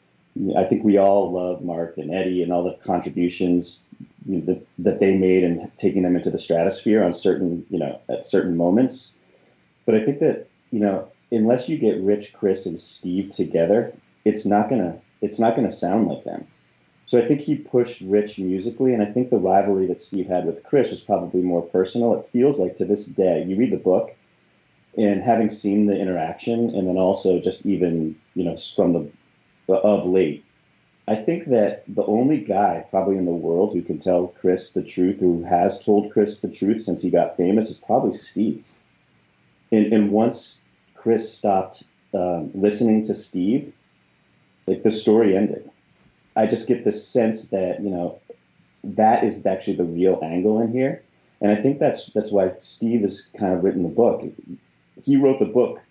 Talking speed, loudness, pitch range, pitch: 190 wpm, -21 LUFS, 90-105 Hz, 95 Hz